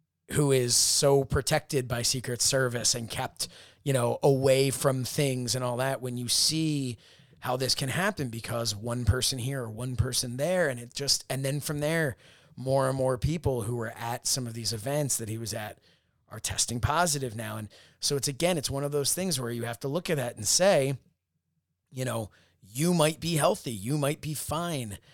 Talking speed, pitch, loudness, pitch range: 205 wpm, 130 Hz, -28 LUFS, 120-145 Hz